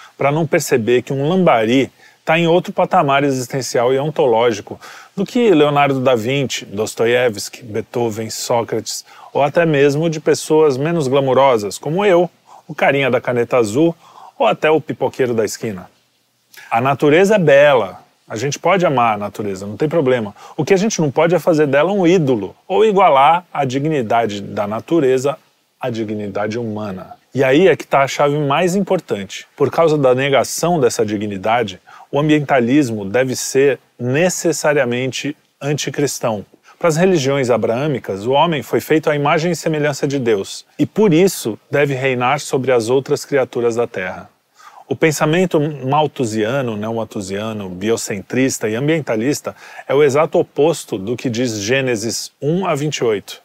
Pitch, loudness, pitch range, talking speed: 140 Hz, -16 LUFS, 120-160 Hz, 155 wpm